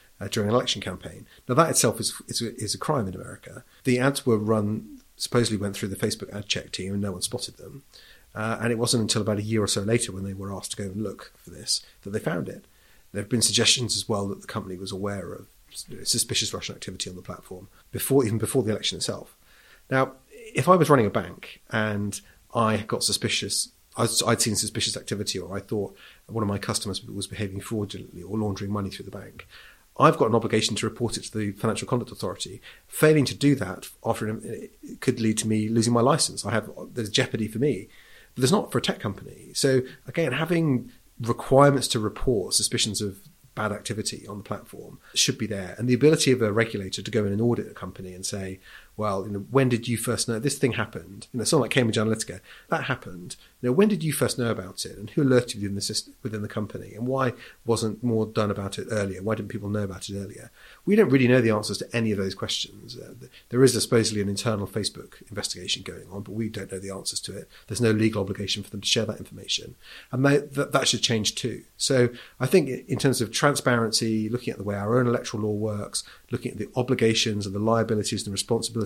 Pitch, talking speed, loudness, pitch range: 110 Hz, 235 wpm, -25 LUFS, 100-125 Hz